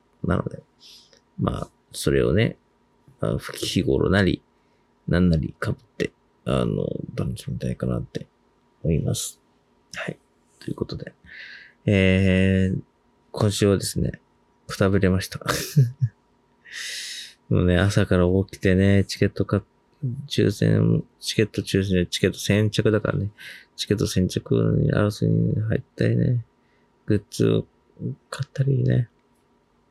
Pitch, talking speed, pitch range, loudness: 105 Hz, 235 characters per minute, 95-125 Hz, -23 LUFS